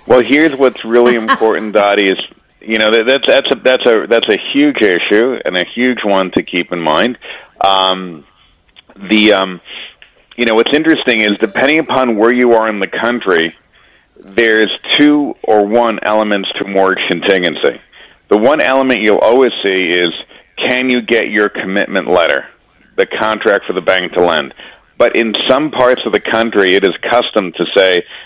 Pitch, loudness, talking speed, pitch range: 110 Hz, -11 LUFS, 175 wpm, 95-125 Hz